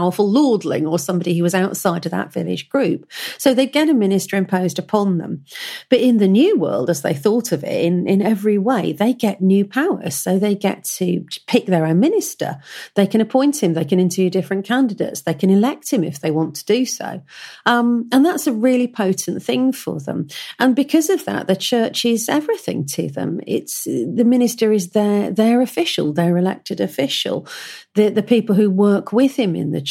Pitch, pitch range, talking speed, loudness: 210 Hz, 185-255 Hz, 205 wpm, -18 LUFS